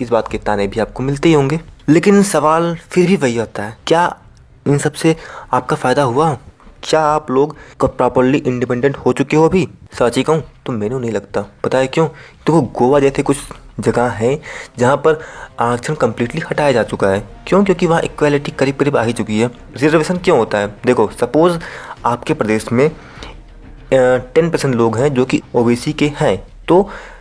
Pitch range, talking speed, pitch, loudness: 120-155 Hz, 100 wpm, 140 Hz, -15 LUFS